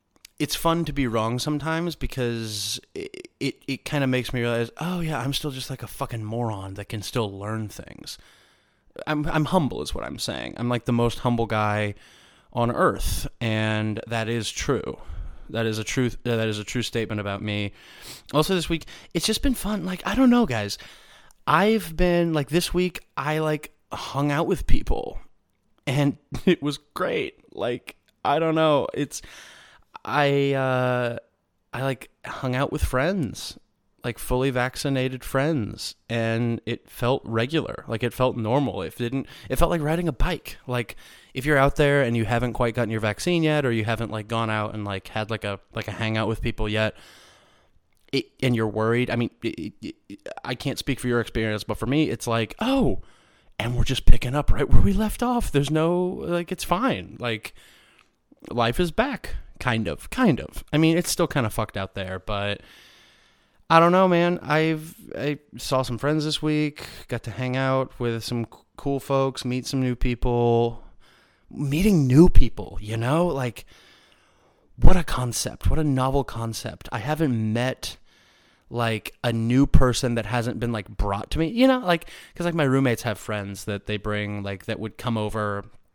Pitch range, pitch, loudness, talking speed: 110-150 Hz, 125 Hz, -25 LUFS, 190 wpm